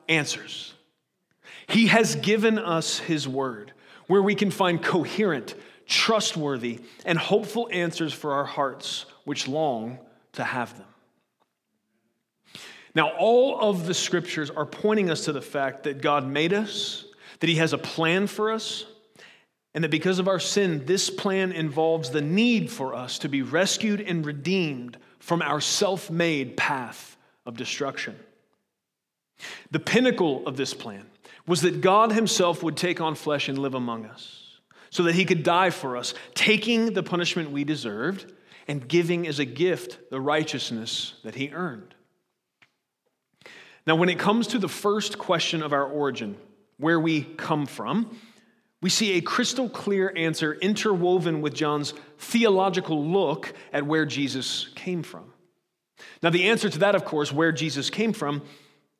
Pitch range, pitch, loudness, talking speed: 150-200 Hz, 170 Hz, -25 LUFS, 155 wpm